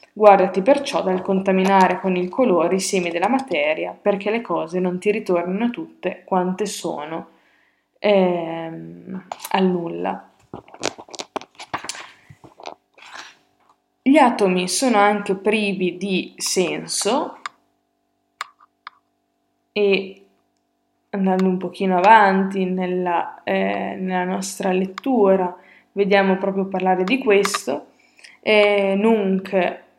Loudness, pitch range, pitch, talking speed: -19 LUFS, 185-215 Hz, 195 Hz, 95 wpm